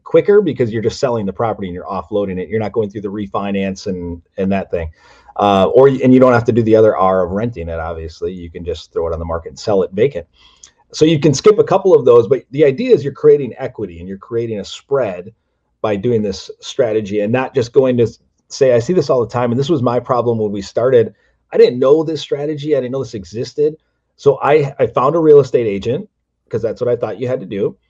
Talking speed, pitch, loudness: 255 wpm, 120 Hz, -15 LUFS